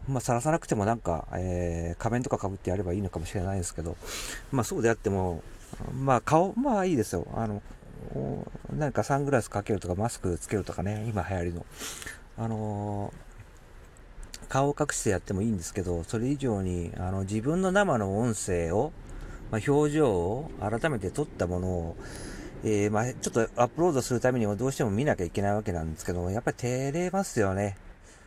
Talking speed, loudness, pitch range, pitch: 390 characters per minute, -29 LUFS, 90-125 Hz, 105 Hz